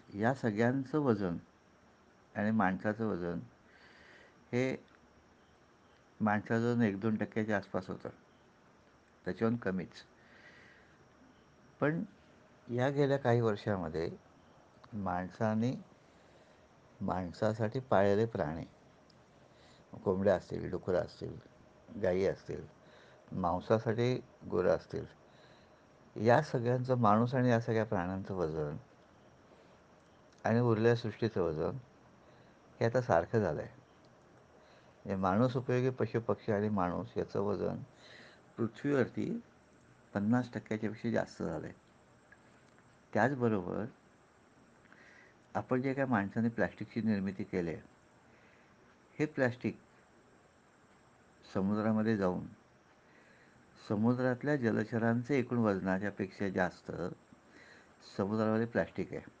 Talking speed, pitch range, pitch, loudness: 90 wpm, 100-120 Hz, 110 Hz, -34 LUFS